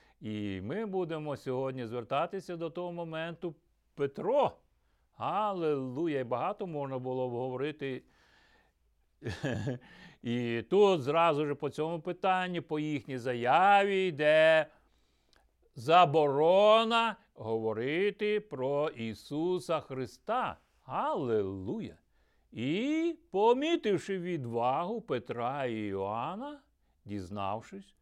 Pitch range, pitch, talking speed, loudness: 125-185 Hz, 155 Hz, 85 wpm, -31 LUFS